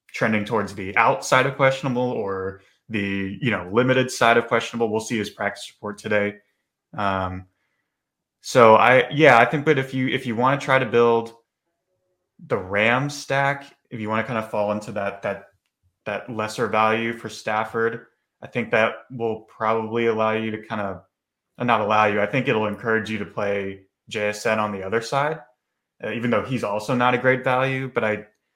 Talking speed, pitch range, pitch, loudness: 190 wpm, 105-125 Hz, 115 Hz, -22 LUFS